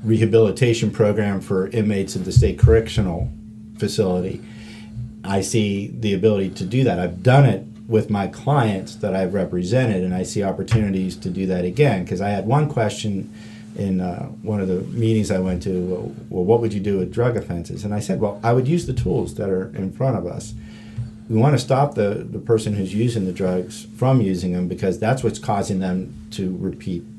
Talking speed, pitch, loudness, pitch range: 205 wpm, 105 Hz, -21 LUFS, 95-115 Hz